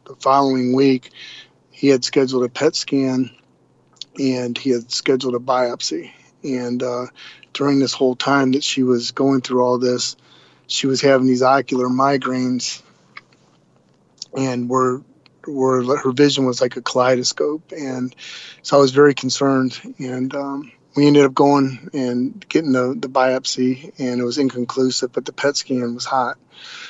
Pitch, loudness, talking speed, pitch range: 130 Hz, -18 LUFS, 155 wpm, 125-140 Hz